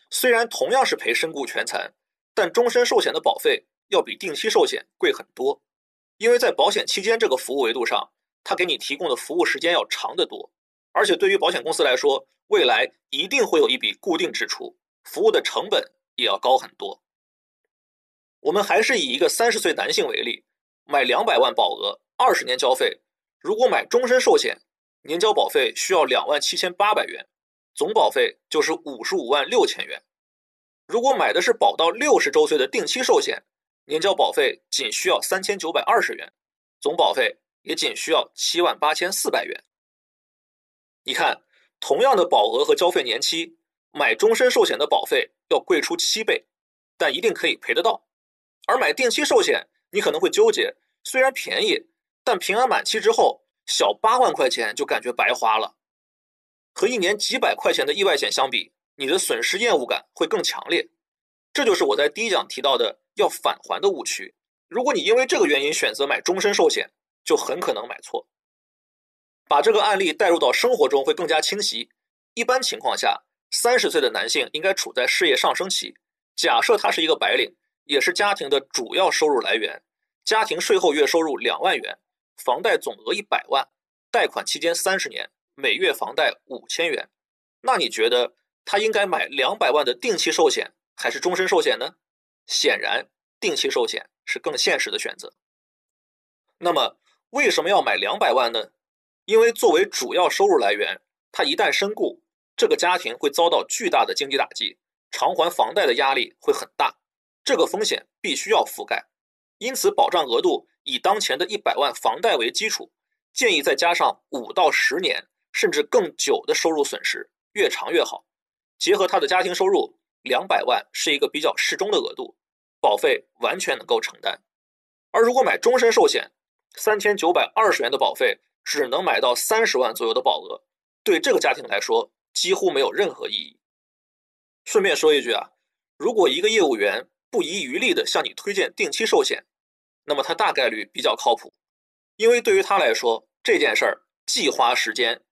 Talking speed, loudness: 275 characters per minute, -21 LUFS